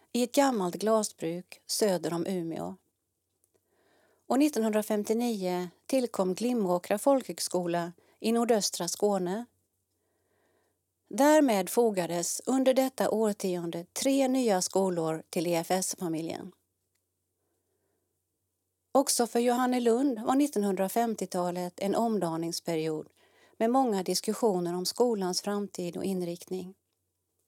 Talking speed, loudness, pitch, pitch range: 90 wpm, -29 LUFS, 190 Hz, 175-235 Hz